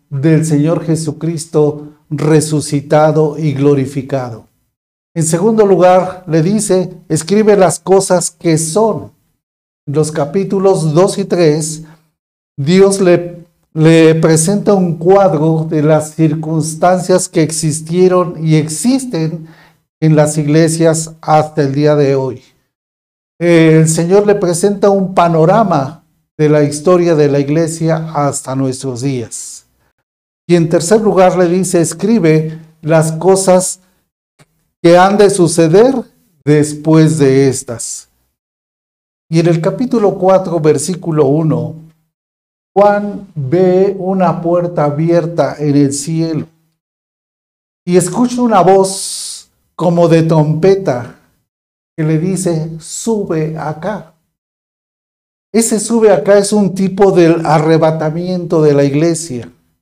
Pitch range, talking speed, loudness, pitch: 155-185 Hz, 110 wpm, -11 LUFS, 160 Hz